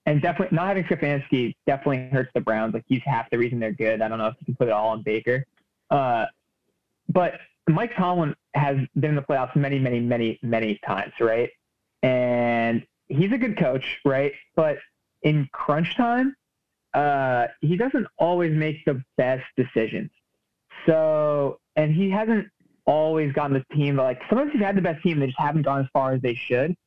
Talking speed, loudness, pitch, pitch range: 190 wpm, -24 LUFS, 140 Hz, 125-160 Hz